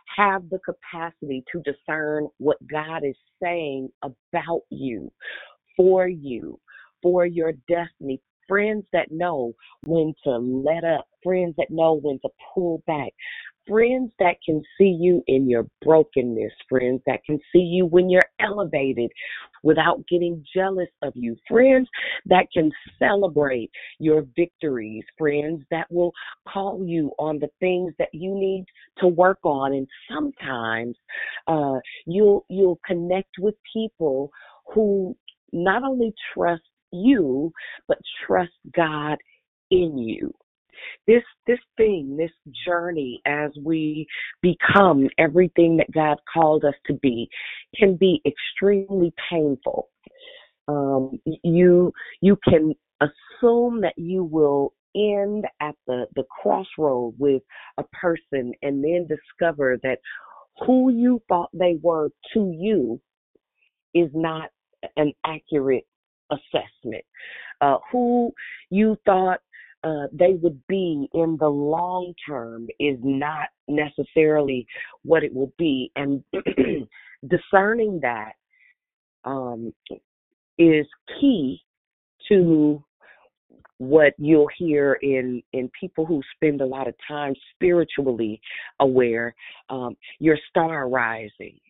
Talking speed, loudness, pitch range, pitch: 120 wpm, -22 LUFS, 145-185 Hz, 160 Hz